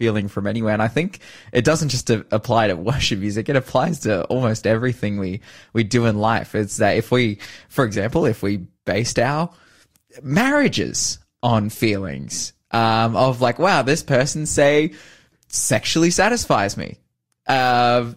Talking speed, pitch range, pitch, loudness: 155 wpm, 105-135 Hz, 115 Hz, -19 LUFS